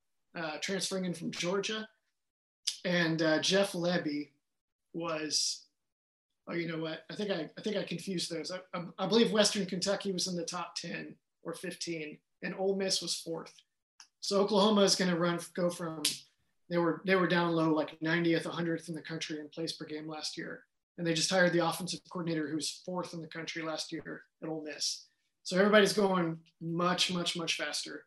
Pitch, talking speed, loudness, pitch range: 170 Hz, 190 wpm, -32 LUFS, 160-185 Hz